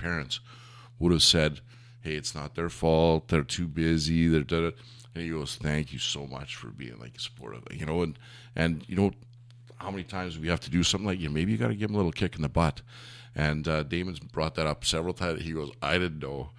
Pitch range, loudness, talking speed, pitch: 80-100 Hz, -29 LUFS, 245 wpm, 85 Hz